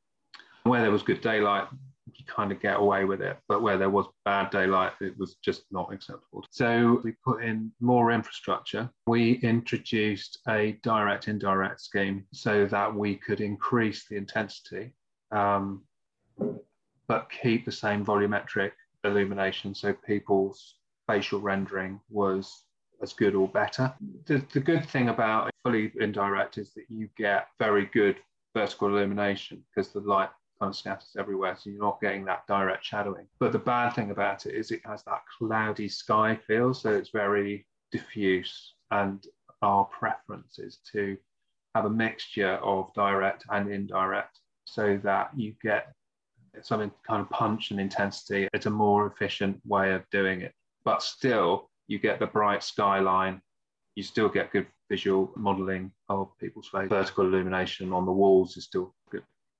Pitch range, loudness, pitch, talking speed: 100-110 Hz, -28 LUFS, 100 Hz, 155 wpm